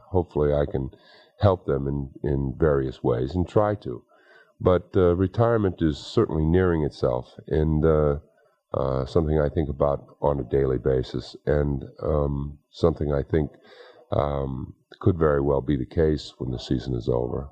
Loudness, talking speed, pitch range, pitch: -25 LUFS, 160 wpm, 70-80 Hz, 75 Hz